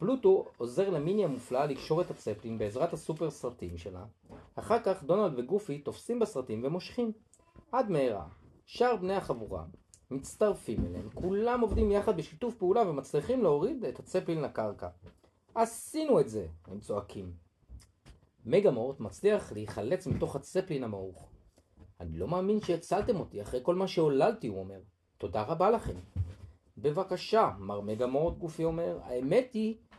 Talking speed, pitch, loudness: 140 wpm, 140 Hz, -32 LUFS